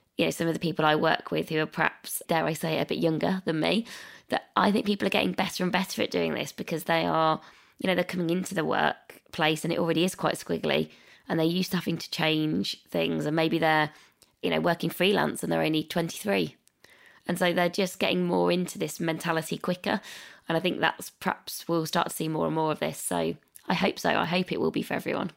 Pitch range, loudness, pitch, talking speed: 160-180 Hz, -27 LUFS, 165 Hz, 240 wpm